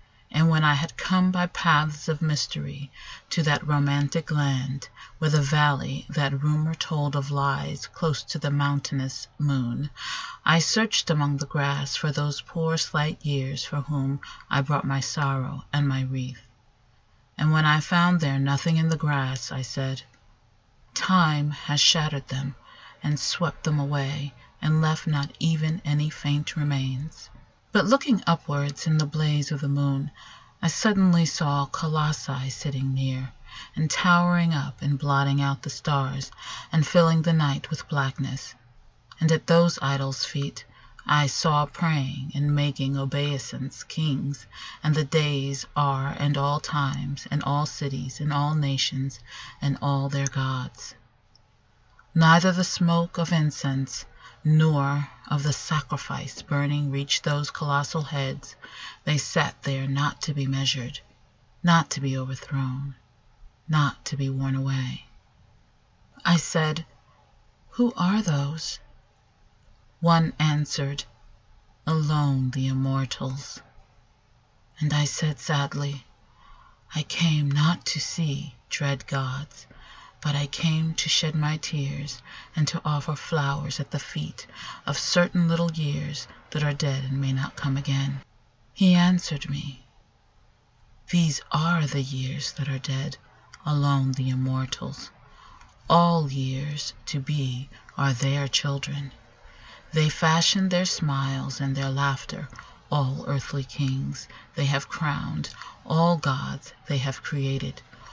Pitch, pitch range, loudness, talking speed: 145 Hz, 135-155 Hz, -25 LUFS, 135 wpm